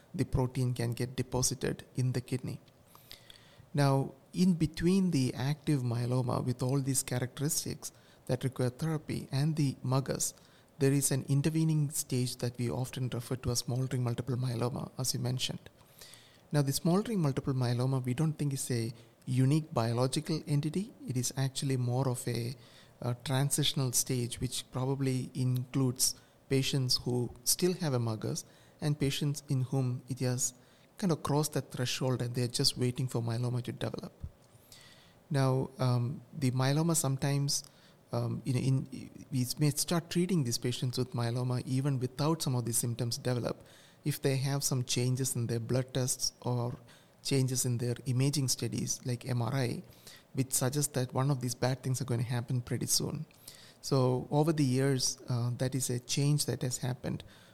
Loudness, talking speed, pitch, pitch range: -32 LUFS, 165 wpm, 130 Hz, 125-140 Hz